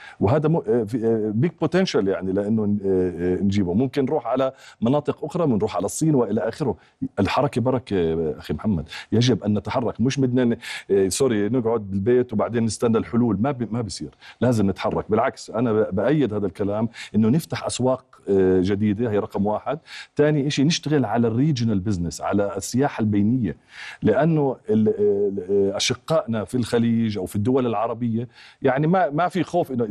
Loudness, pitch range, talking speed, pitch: -22 LUFS, 100-135 Hz, 155 wpm, 115 Hz